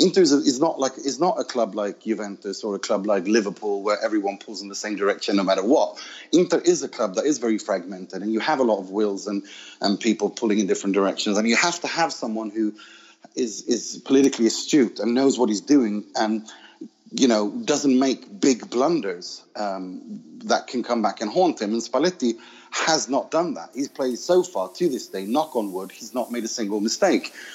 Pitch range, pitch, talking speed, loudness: 105-150 Hz, 115 Hz, 225 wpm, -23 LUFS